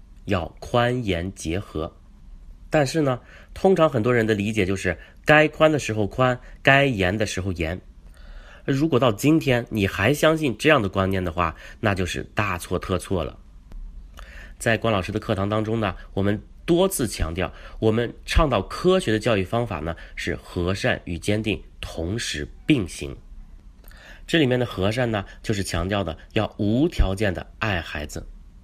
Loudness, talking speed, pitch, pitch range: -23 LUFS, 235 characters per minute, 95 Hz, 85-120 Hz